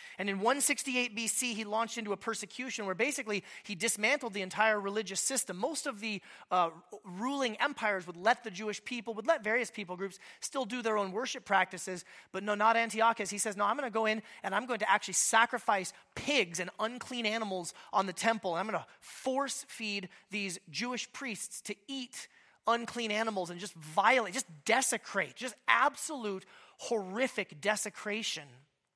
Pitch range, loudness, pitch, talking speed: 195-240 Hz, -33 LUFS, 215 Hz, 175 wpm